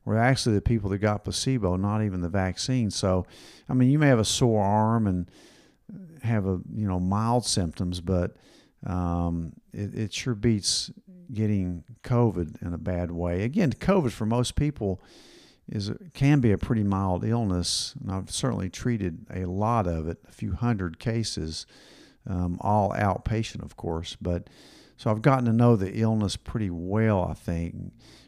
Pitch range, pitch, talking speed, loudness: 90-120 Hz, 105 Hz, 170 wpm, -26 LUFS